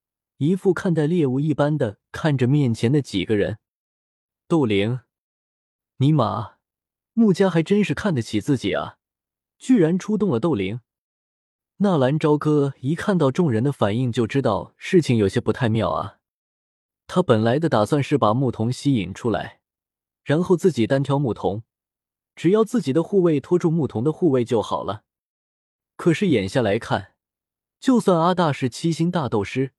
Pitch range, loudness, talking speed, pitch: 115-170 Hz, -21 LUFS, 235 characters per minute, 140 Hz